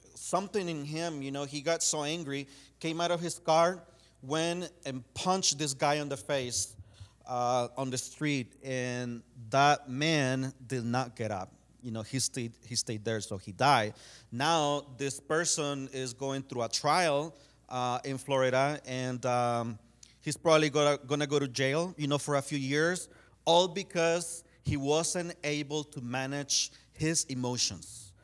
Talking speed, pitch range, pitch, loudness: 165 wpm, 125-155 Hz, 140 Hz, -31 LUFS